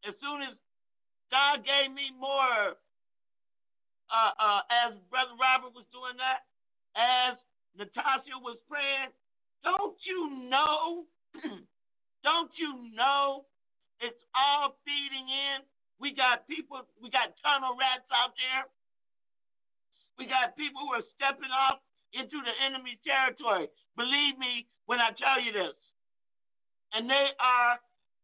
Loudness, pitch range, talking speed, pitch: -29 LUFS, 245-280 Hz, 125 wpm, 265 Hz